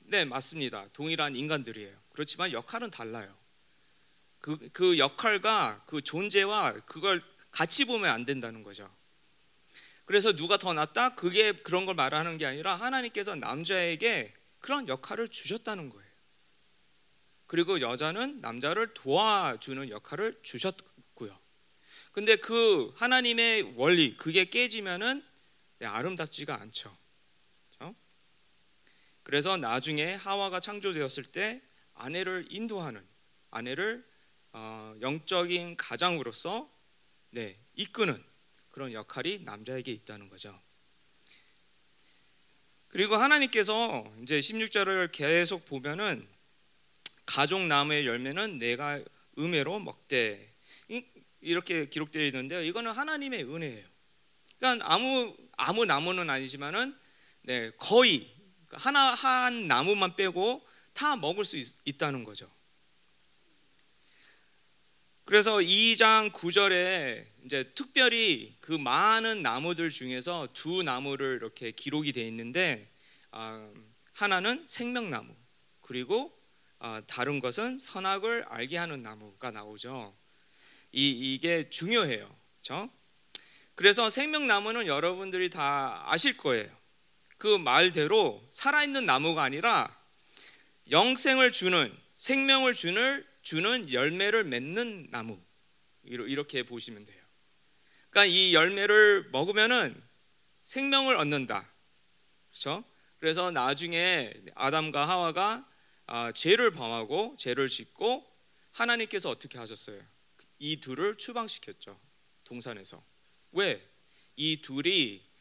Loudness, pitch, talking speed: -27 LUFS, 170 Hz, 245 characters per minute